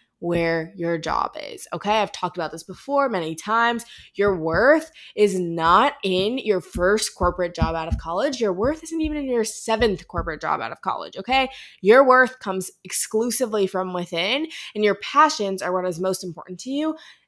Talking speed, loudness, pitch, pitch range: 185 wpm, -22 LUFS, 205 Hz, 180-255 Hz